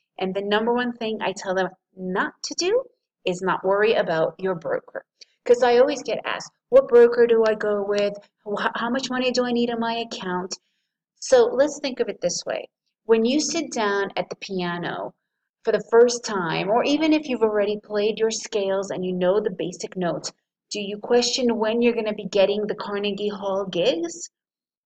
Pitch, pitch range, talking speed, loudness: 220 Hz, 195-245 Hz, 200 wpm, -23 LUFS